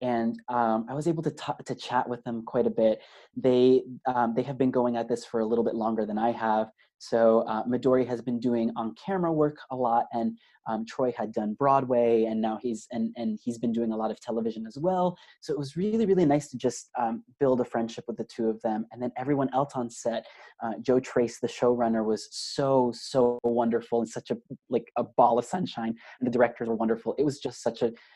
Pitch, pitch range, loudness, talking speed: 120 Hz, 115-130 Hz, -28 LUFS, 235 wpm